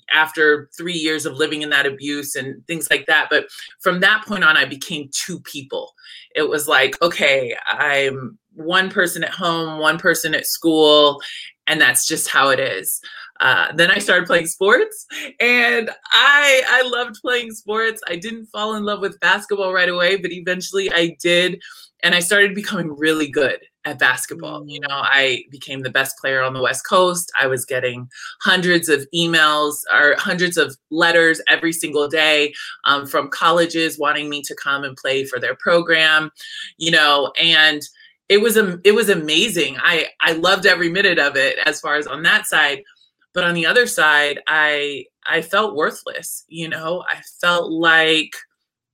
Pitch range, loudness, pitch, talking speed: 150-200 Hz, -16 LUFS, 170 Hz, 180 wpm